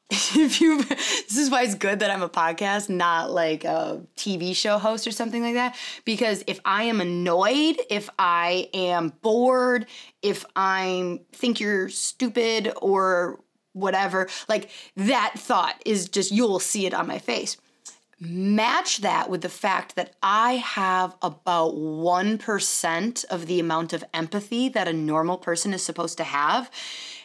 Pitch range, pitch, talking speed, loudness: 180-235 Hz, 195 Hz, 160 wpm, -24 LUFS